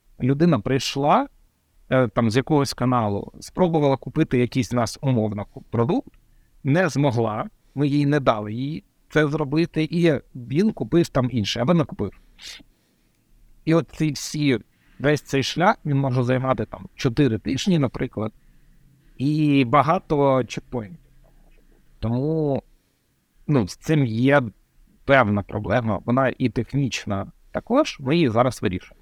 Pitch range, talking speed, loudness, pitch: 120-150 Hz, 125 wpm, -22 LUFS, 135 Hz